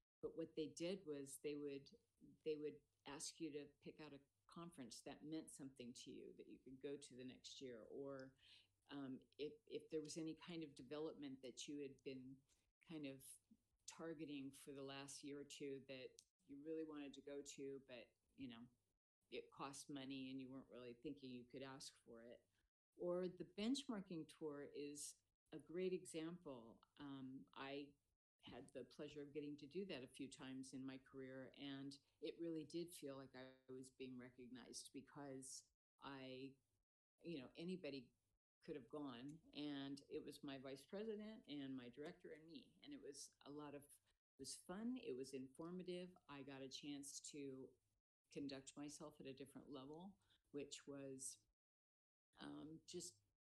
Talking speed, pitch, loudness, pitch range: 175 wpm, 140 Hz, -55 LUFS, 130-155 Hz